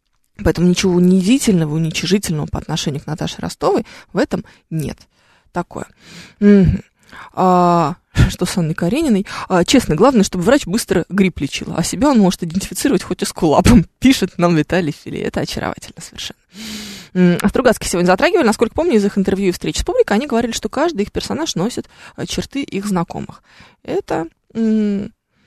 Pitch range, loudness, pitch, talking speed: 175-215 Hz, -16 LUFS, 190 Hz, 160 wpm